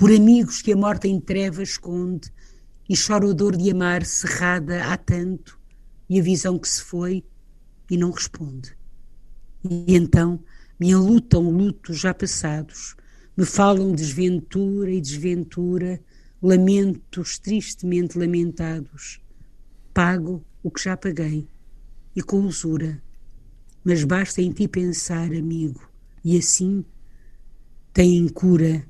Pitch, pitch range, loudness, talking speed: 175 Hz, 160-185 Hz, -21 LUFS, 125 wpm